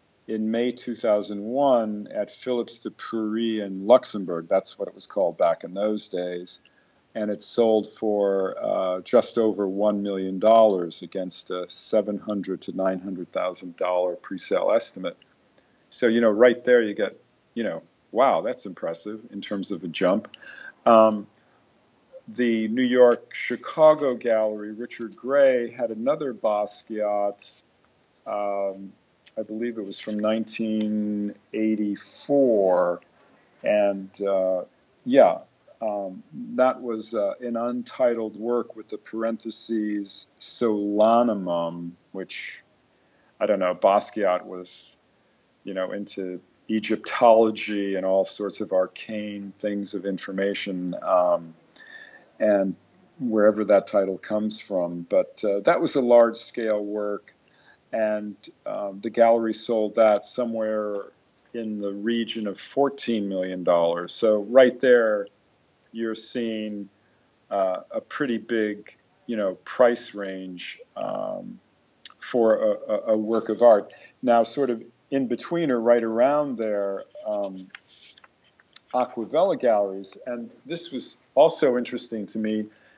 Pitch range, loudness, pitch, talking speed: 100-115 Hz, -24 LUFS, 110 Hz, 125 wpm